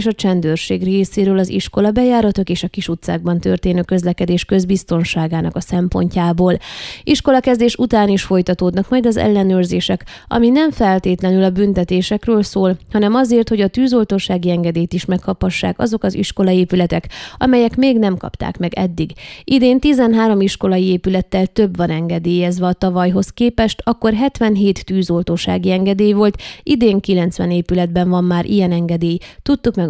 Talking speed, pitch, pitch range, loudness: 140 wpm, 190 Hz, 180-215 Hz, -15 LUFS